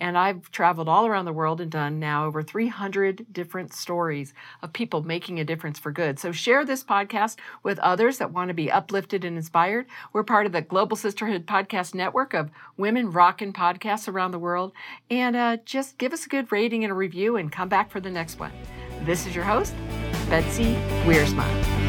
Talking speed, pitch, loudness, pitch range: 200 wpm, 185 Hz, -25 LUFS, 160-215 Hz